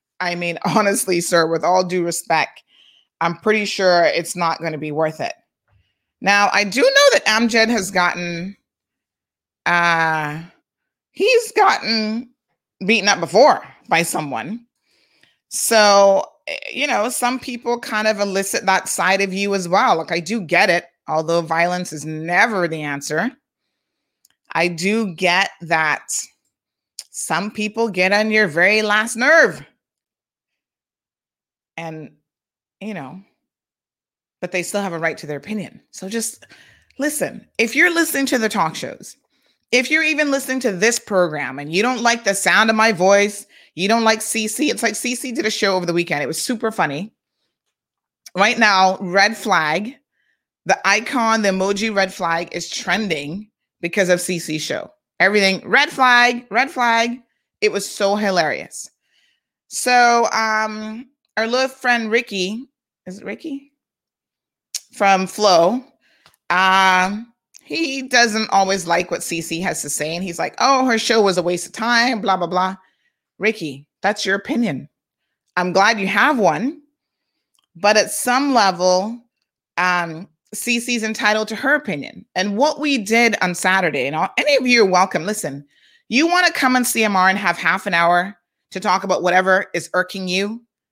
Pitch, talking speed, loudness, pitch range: 200 Hz, 155 wpm, -17 LUFS, 180-235 Hz